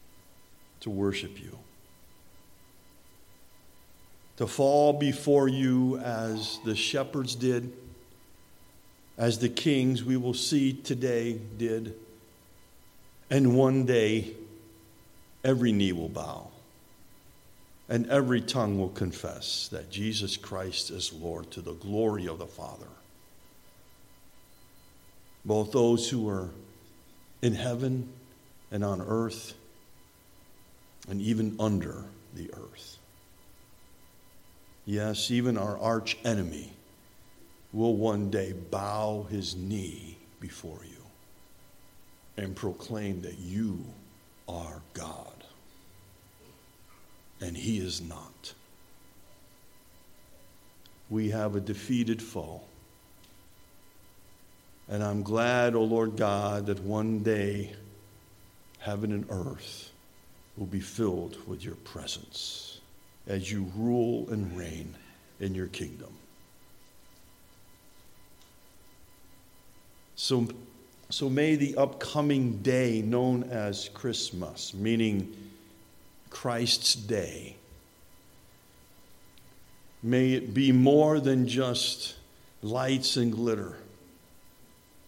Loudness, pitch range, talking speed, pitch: -29 LUFS, 95-120 Hz, 90 wpm, 110 Hz